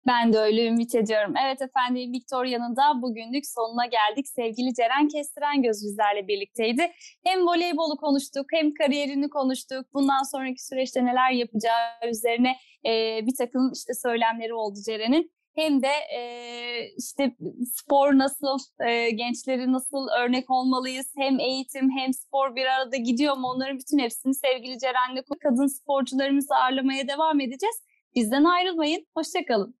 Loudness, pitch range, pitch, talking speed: -25 LUFS, 240-280 Hz, 260 Hz, 135 wpm